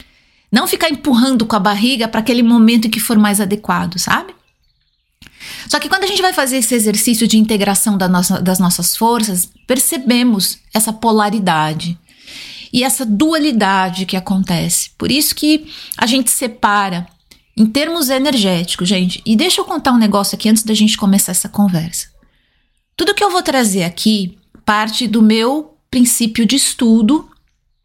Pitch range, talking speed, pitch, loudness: 200-260 Hz, 160 wpm, 225 Hz, -13 LUFS